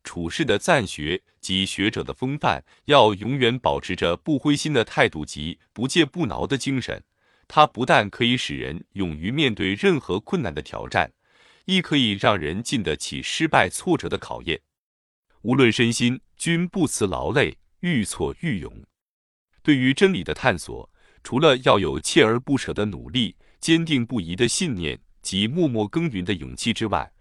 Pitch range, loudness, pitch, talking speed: 105-150 Hz, -22 LUFS, 125 Hz, 245 characters per minute